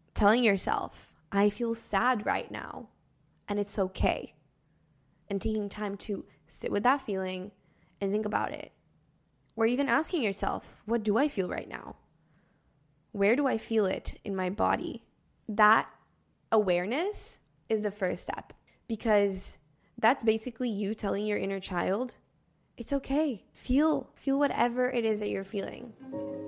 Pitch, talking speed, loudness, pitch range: 210 Hz, 145 wpm, -30 LUFS, 195-240 Hz